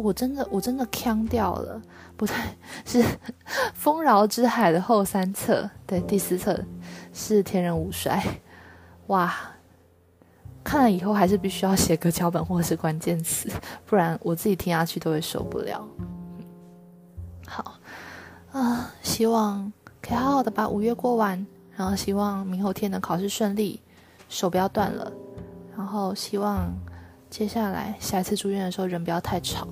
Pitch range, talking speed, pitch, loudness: 165-210 Hz, 230 characters per minute, 190 Hz, -25 LUFS